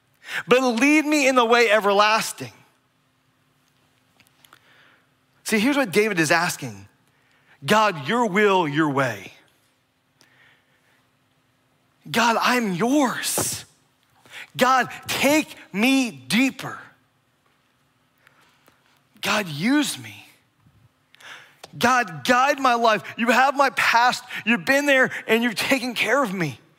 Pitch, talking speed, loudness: 210 Hz, 100 wpm, -20 LUFS